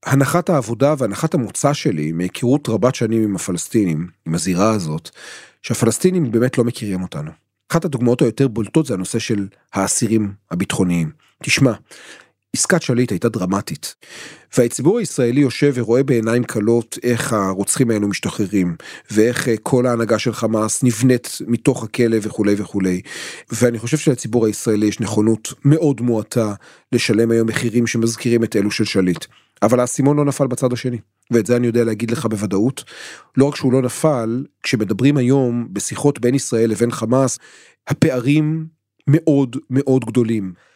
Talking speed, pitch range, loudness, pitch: 145 wpm, 110-135 Hz, -18 LUFS, 120 Hz